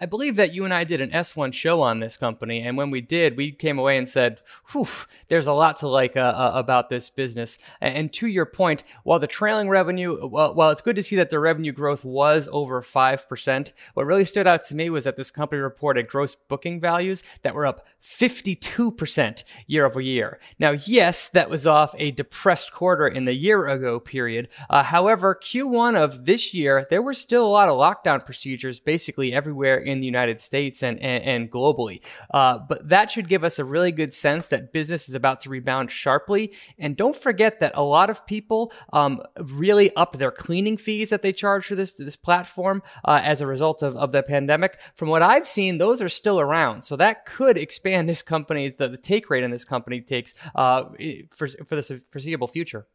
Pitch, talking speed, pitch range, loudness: 150 Hz, 215 wpm, 135-180 Hz, -21 LUFS